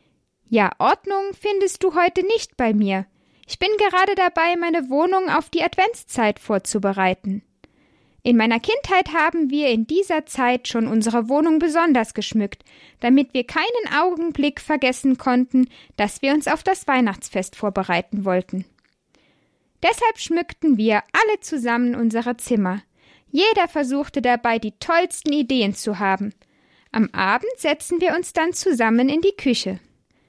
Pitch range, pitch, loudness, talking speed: 225-345 Hz, 280 Hz, -20 LUFS, 140 wpm